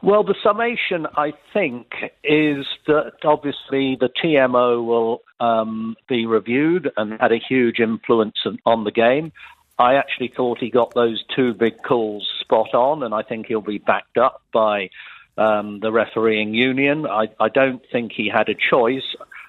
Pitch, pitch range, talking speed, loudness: 120 Hz, 110-140 Hz, 165 wpm, -19 LUFS